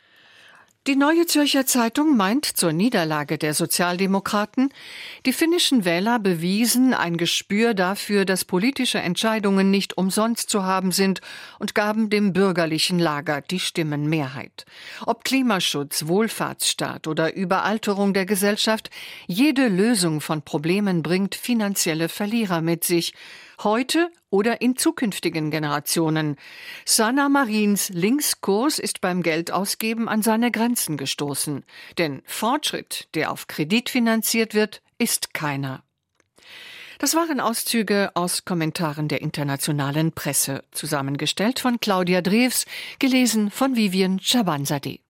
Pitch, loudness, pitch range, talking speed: 200 Hz, -22 LUFS, 170-240 Hz, 115 wpm